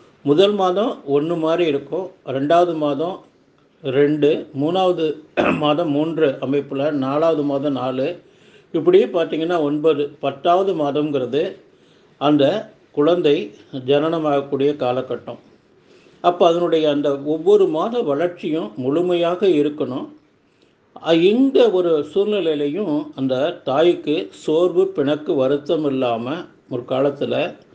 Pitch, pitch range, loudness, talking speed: 150 Hz, 140-175 Hz, -19 LUFS, 95 wpm